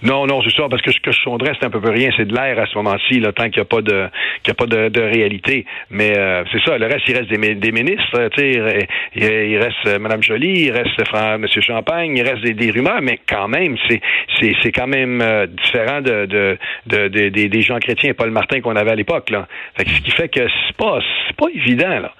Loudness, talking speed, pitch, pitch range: -15 LUFS, 260 wpm, 115 Hz, 105-125 Hz